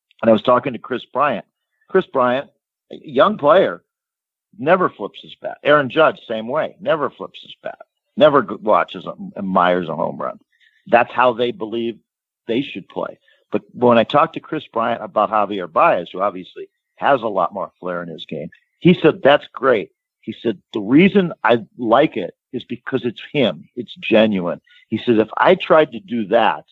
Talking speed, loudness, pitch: 185 wpm, -18 LUFS, 130 Hz